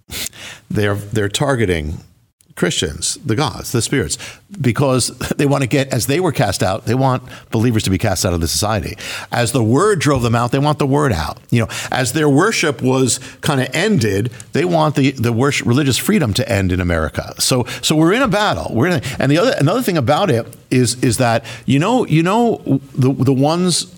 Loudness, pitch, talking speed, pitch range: -16 LUFS, 130 Hz, 215 wpm, 115-145 Hz